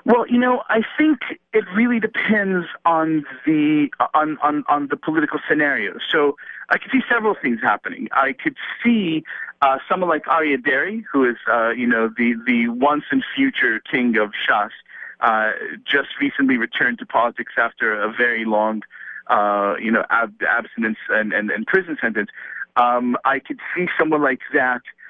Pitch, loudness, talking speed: 155 Hz, -19 LUFS, 170 wpm